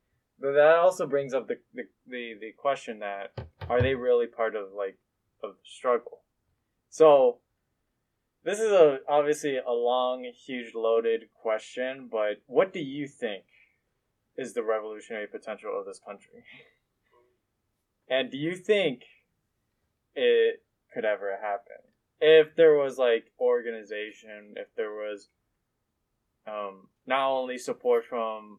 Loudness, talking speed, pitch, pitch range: -27 LUFS, 130 wpm, 125 Hz, 110-165 Hz